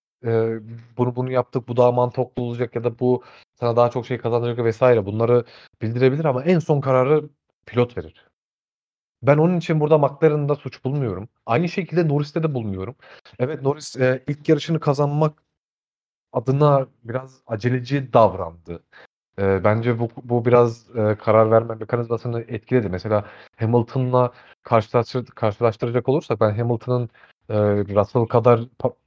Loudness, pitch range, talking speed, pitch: -21 LUFS, 115-135 Hz, 140 wpm, 125 Hz